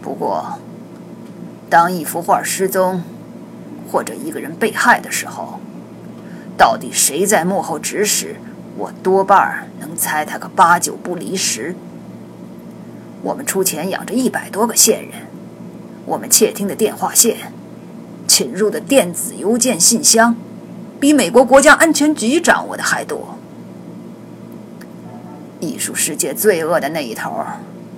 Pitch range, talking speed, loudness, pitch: 185-245 Hz, 195 characters per minute, -15 LUFS, 210 Hz